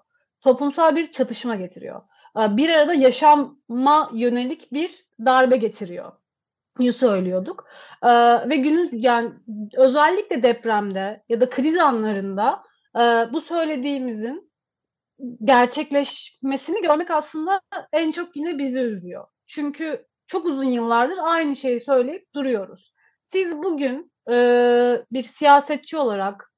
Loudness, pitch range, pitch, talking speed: -20 LUFS, 235-310 Hz, 265 Hz, 100 wpm